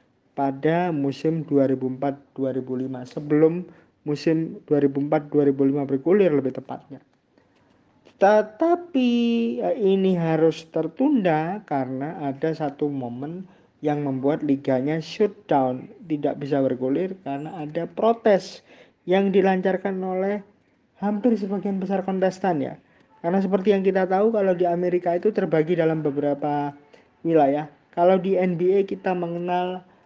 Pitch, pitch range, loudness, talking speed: 165 Hz, 145-190 Hz, -23 LUFS, 105 wpm